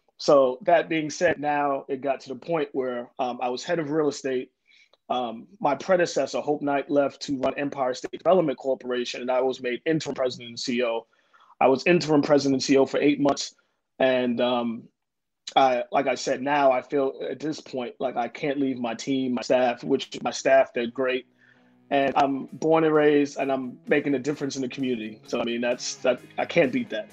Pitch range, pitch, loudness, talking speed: 125-145 Hz, 135 Hz, -25 LUFS, 210 wpm